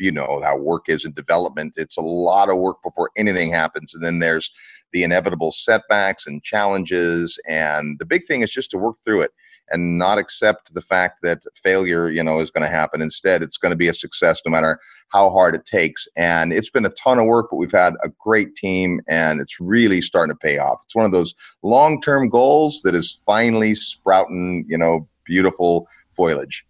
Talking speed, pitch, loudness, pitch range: 210 wpm, 90 Hz, -18 LUFS, 80-105 Hz